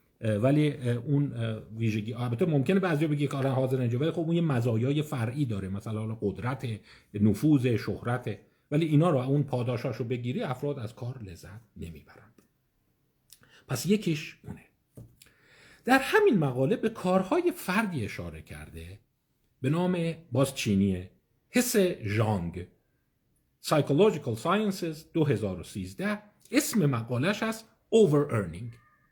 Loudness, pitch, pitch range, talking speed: -28 LUFS, 130 Hz, 110-160 Hz, 120 wpm